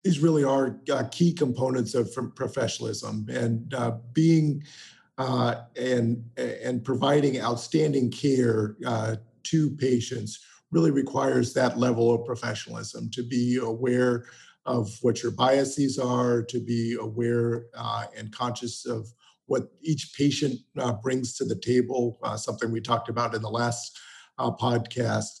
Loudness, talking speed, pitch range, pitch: -27 LUFS, 140 wpm, 115-135 Hz, 125 Hz